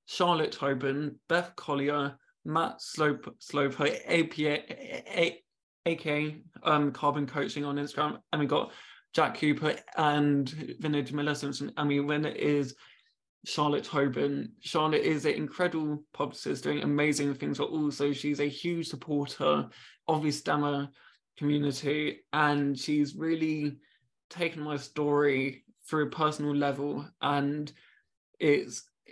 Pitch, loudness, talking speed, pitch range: 145 Hz, -30 LUFS, 130 wpm, 145-150 Hz